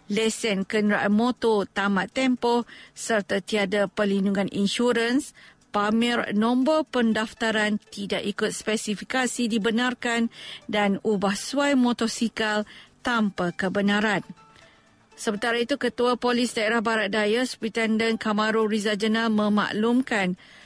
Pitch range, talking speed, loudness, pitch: 205-235 Hz, 100 wpm, -24 LUFS, 220 Hz